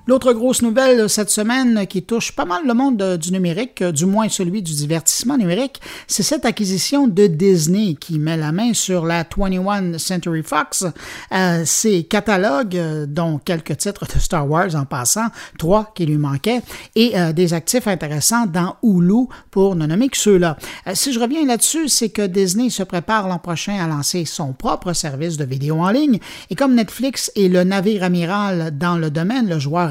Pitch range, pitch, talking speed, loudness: 170-225 Hz, 190 Hz, 185 wpm, -17 LUFS